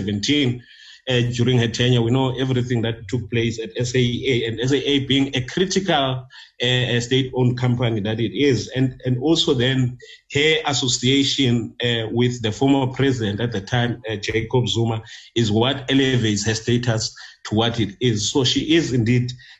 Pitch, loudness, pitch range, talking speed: 125 Hz, -20 LUFS, 115-130 Hz, 160 wpm